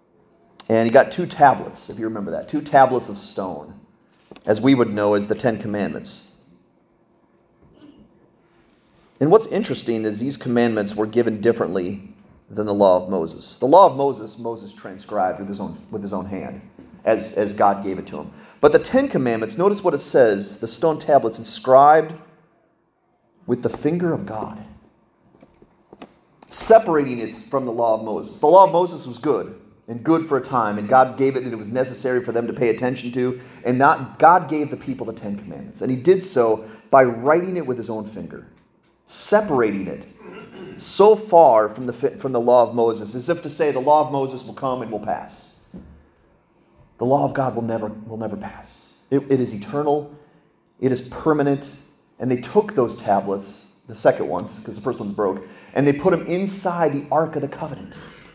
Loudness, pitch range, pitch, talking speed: -20 LUFS, 110-150 Hz, 125 Hz, 190 wpm